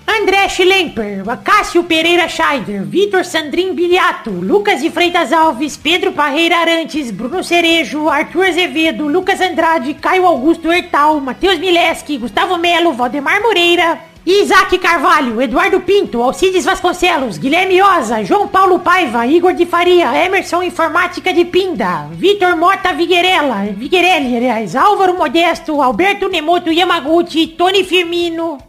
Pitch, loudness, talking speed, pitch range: 345 Hz, -12 LUFS, 120 wpm, 315-365 Hz